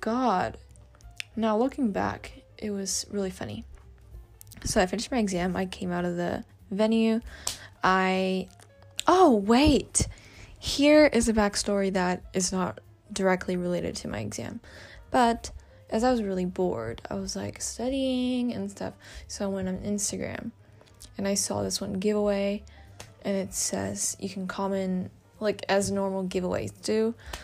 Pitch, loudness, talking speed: 190 Hz, -27 LUFS, 150 wpm